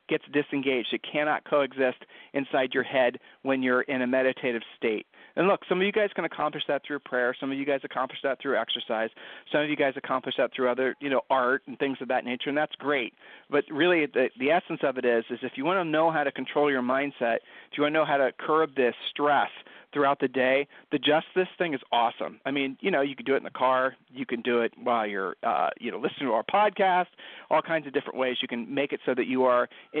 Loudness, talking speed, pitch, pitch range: -27 LUFS, 255 wpm, 135 Hz, 130-150 Hz